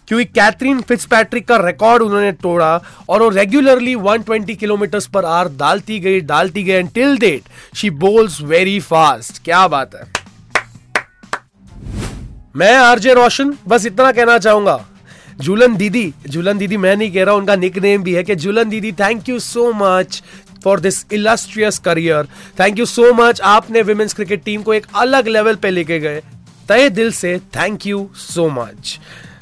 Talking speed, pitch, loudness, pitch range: 160 wpm, 205 Hz, -13 LUFS, 185-230 Hz